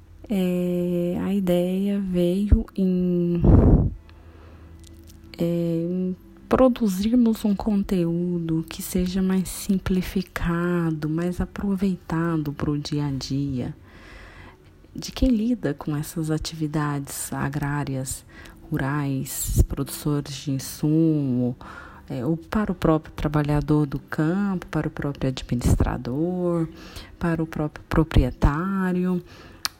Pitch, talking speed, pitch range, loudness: 160 Hz, 95 wpm, 140-180 Hz, -24 LUFS